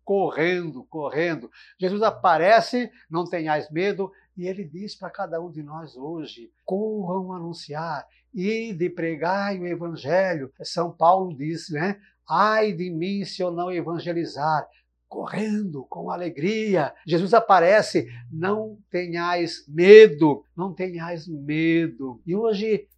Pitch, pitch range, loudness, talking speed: 180 Hz, 165-195 Hz, -22 LUFS, 125 wpm